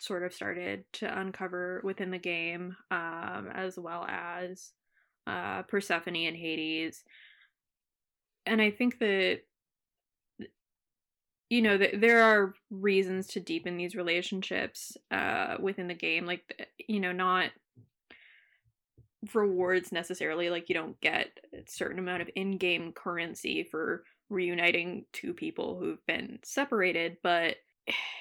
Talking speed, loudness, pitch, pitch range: 125 wpm, -31 LUFS, 180 Hz, 175-200 Hz